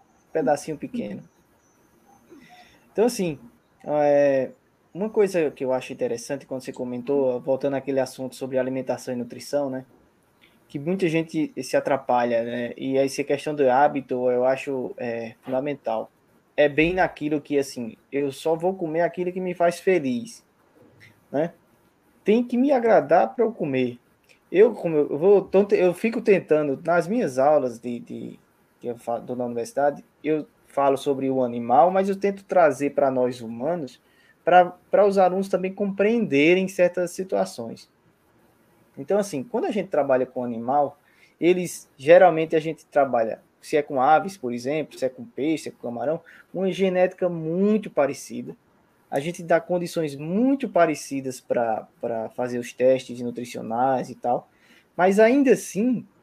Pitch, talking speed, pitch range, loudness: 150 Hz, 150 wpm, 130-180 Hz, -23 LUFS